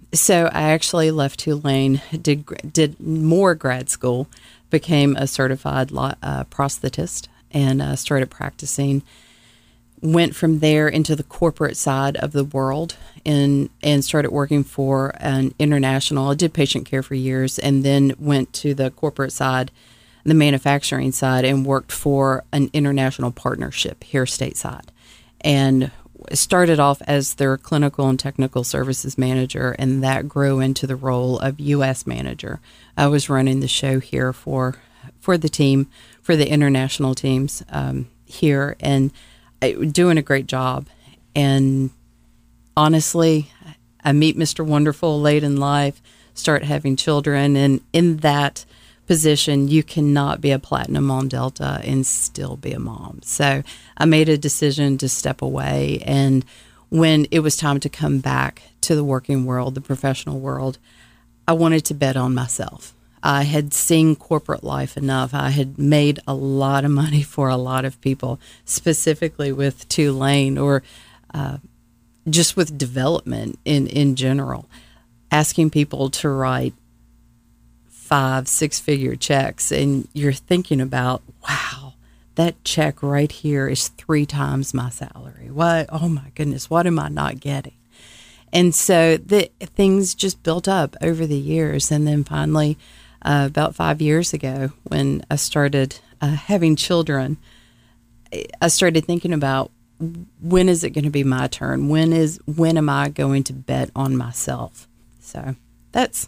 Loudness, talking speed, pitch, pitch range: -19 LUFS, 150 wpm, 140 Hz, 130-150 Hz